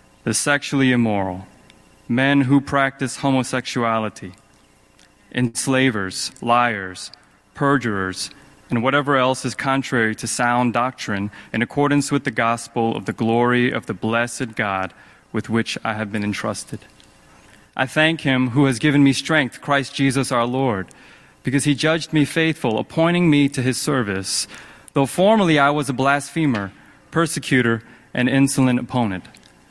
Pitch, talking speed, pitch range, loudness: 130 Hz, 135 wpm, 115-140 Hz, -20 LUFS